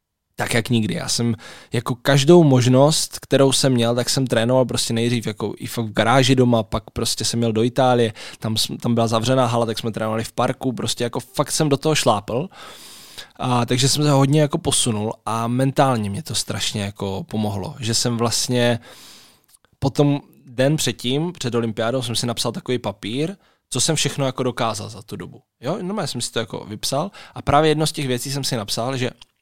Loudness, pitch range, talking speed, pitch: -20 LUFS, 115-135 Hz, 205 wpm, 125 Hz